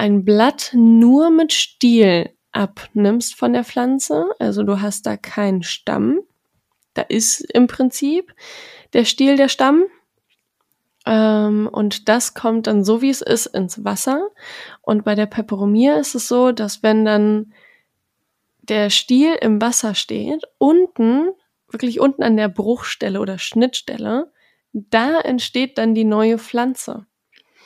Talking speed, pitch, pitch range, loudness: 135 wpm, 235 Hz, 215-275 Hz, -17 LUFS